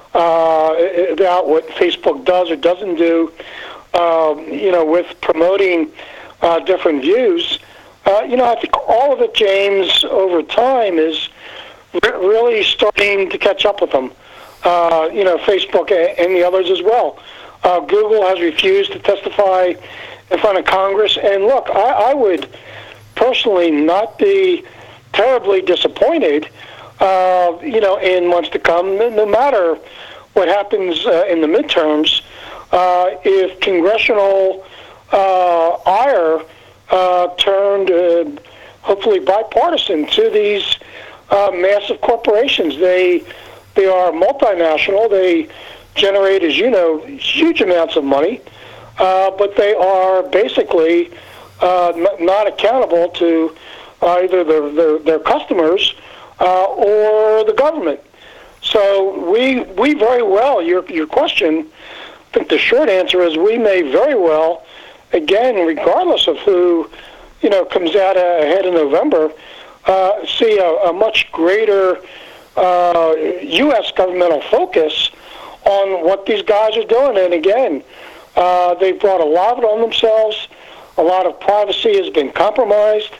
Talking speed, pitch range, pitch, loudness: 135 wpm, 175-230 Hz, 190 Hz, -14 LUFS